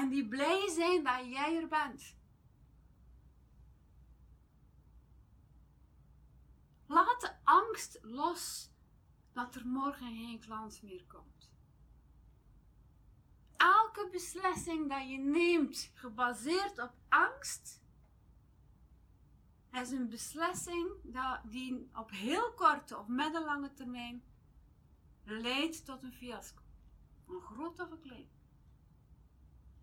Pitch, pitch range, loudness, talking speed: 260 Hz, 220-325 Hz, -35 LUFS, 95 wpm